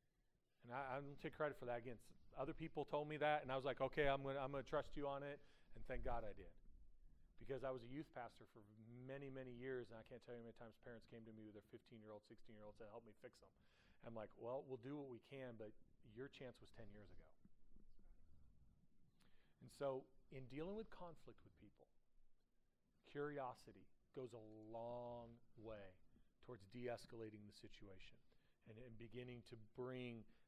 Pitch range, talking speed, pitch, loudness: 110-135 Hz, 205 wpm, 120 Hz, -52 LUFS